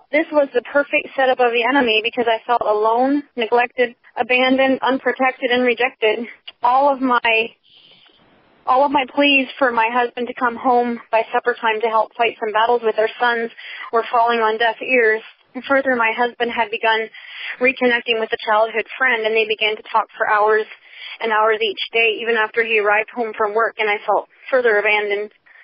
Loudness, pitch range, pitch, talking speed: -17 LUFS, 220-255 Hz, 235 Hz, 185 wpm